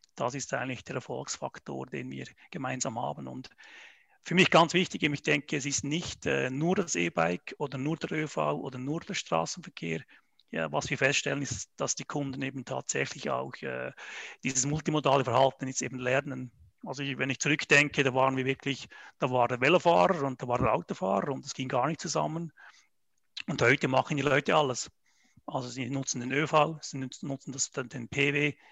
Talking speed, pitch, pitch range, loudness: 190 wpm, 135 Hz, 130-150 Hz, -29 LUFS